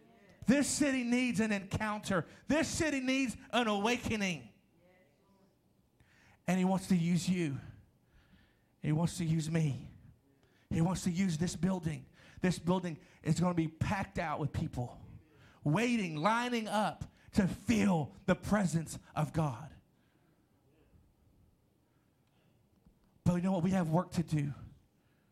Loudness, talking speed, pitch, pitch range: -34 LUFS, 130 wpm, 175 Hz, 155-205 Hz